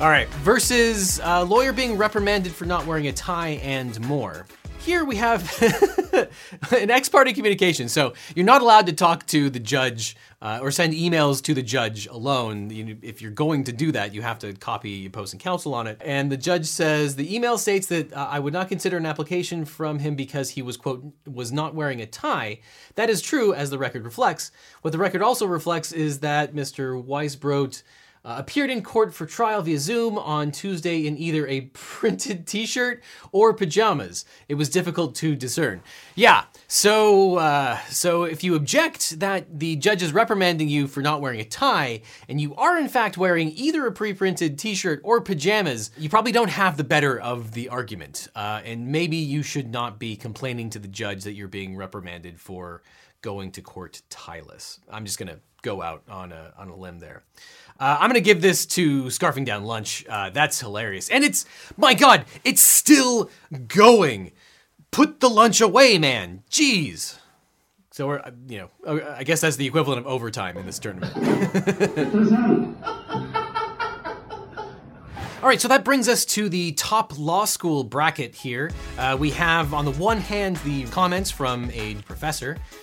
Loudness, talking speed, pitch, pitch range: -21 LUFS, 185 wpm, 155 Hz, 125-200 Hz